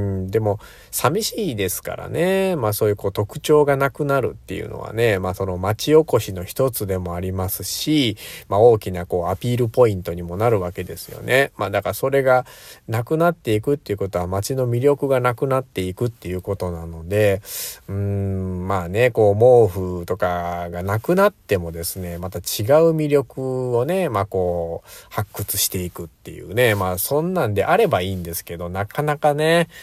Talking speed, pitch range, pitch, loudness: 370 characters per minute, 90-135 Hz, 105 Hz, -20 LUFS